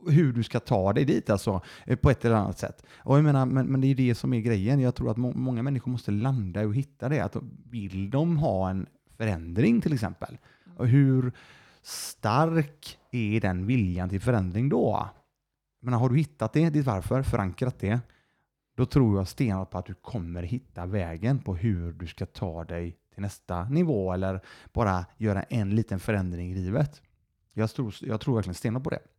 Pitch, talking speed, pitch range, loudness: 115 Hz, 195 wpm, 95-130 Hz, -27 LUFS